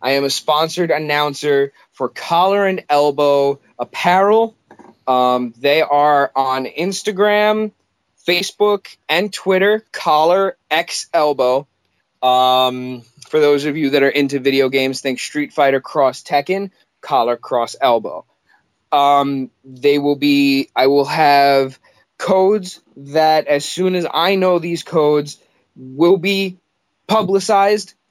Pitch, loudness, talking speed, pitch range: 145 Hz, -16 LUFS, 125 wpm, 135-185 Hz